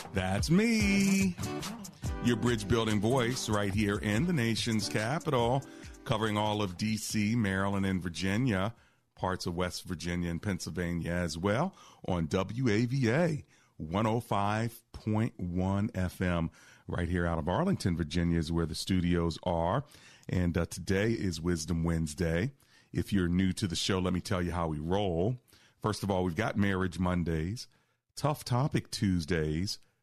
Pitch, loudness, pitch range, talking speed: 100 Hz, -31 LUFS, 90-115 Hz, 140 wpm